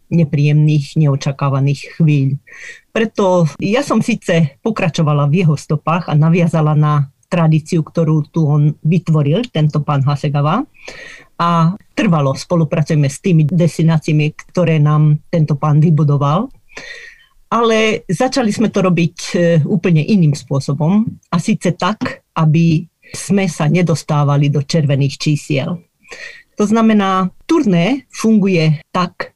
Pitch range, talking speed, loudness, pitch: 150-190 Hz, 115 wpm, -14 LUFS, 165 Hz